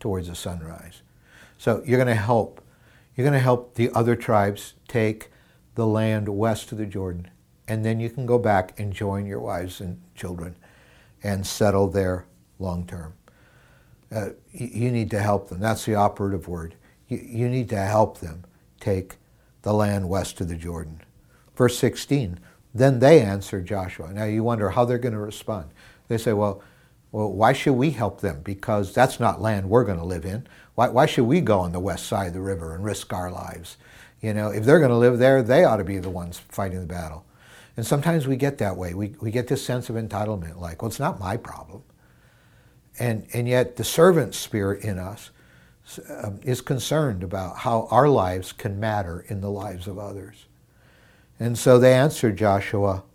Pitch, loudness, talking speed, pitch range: 105 Hz, -23 LUFS, 195 wpm, 95-120 Hz